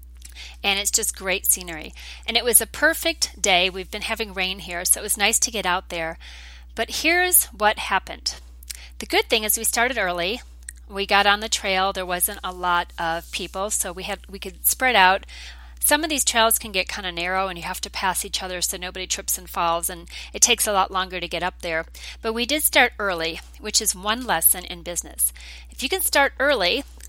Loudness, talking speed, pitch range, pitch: -21 LUFS, 220 wpm, 175-220 Hz, 190 Hz